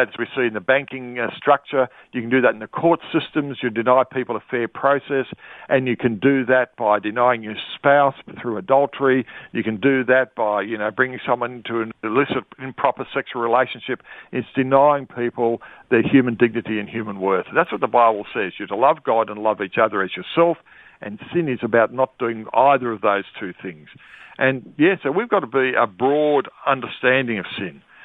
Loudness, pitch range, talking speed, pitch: -20 LUFS, 115-135 Hz, 205 wpm, 125 Hz